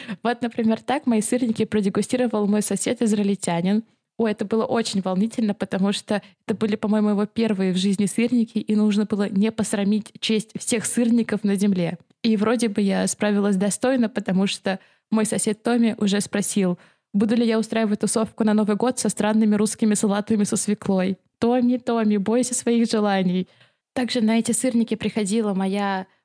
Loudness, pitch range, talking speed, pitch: -22 LUFS, 205-230 Hz, 165 wpm, 215 Hz